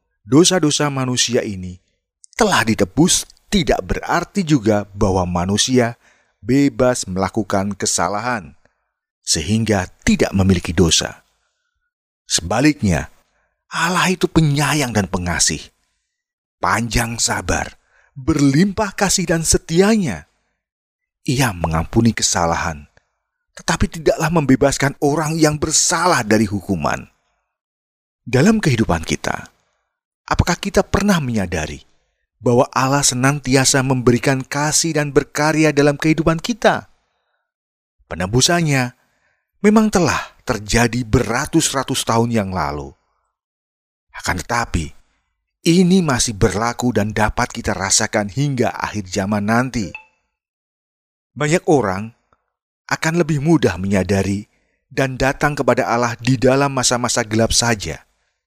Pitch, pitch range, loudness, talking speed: 125 Hz, 100-150 Hz, -17 LUFS, 95 wpm